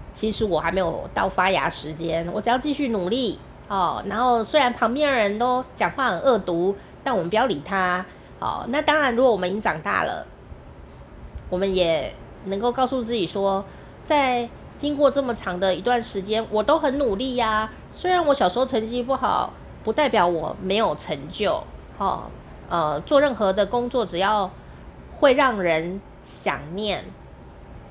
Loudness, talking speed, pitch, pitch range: -23 LUFS, 245 characters per minute, 220 Hz, 185-255 Hz